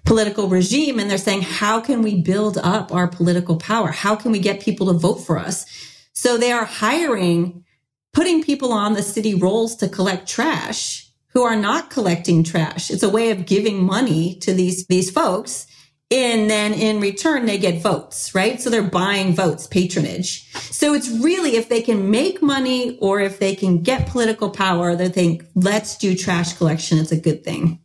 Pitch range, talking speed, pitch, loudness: 180-225 Hz, 190 wpm, 195 Hz, -19 LUFS